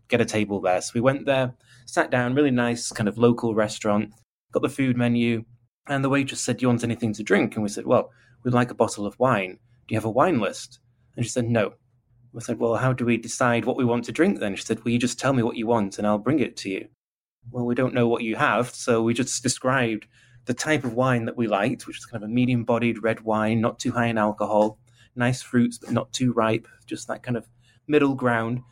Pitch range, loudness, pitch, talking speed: 115-125 Hz, -24 LUFS, 120 Hz, 260 wpm